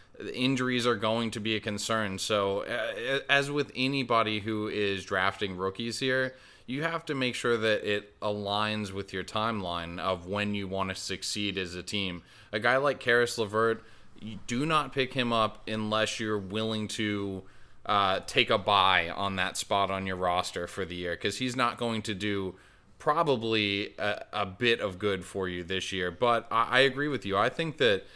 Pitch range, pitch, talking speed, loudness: 100-120 Hz, 105 Hz, 190 wpm, -29 LUFS